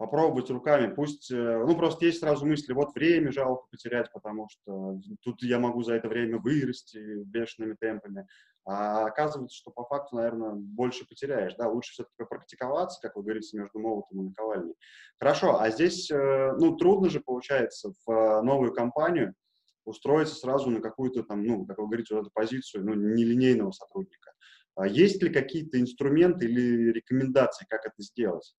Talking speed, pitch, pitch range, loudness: 160 wpm, 120 Hz, 110-140 Hz, -28 LUFS